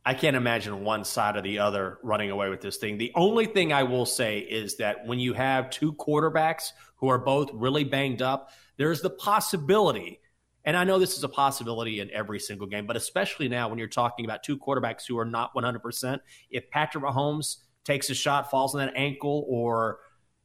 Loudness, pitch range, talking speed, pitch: -27 LUFS, 115-145 Hz, 205 wpm, 130 Hz